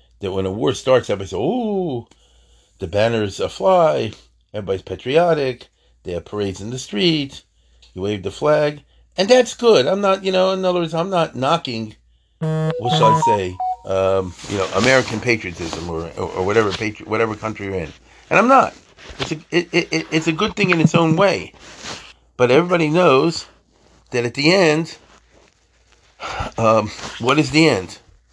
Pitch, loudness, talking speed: 130 Hz, -18 LUFS, 175 wpm